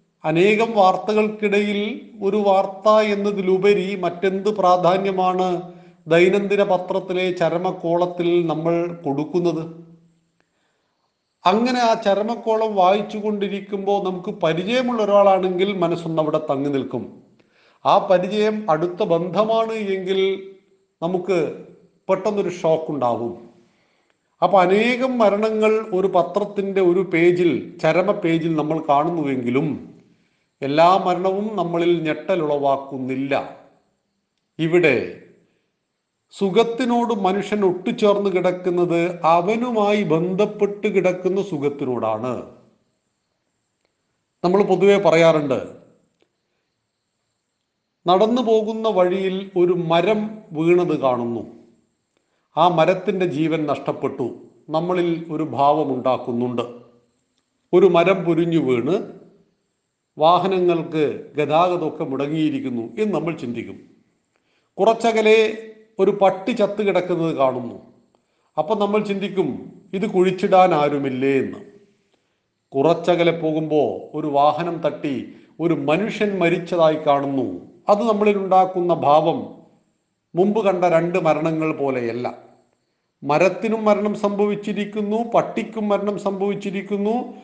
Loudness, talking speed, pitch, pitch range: -20 LUFS, 85 wpm, 185 Hz, 160-205 Hz